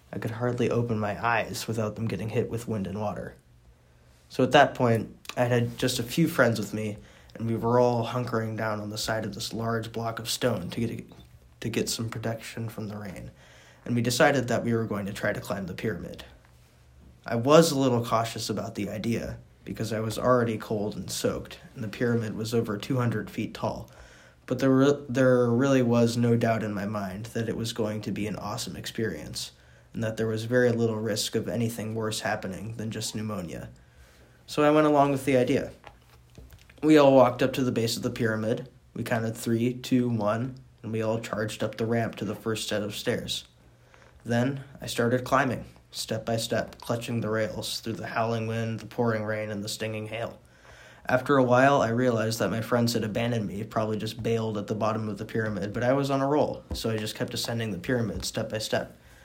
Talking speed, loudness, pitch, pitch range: 215 wpm, -27 LUFS, 115 Hz, 105-120 Hz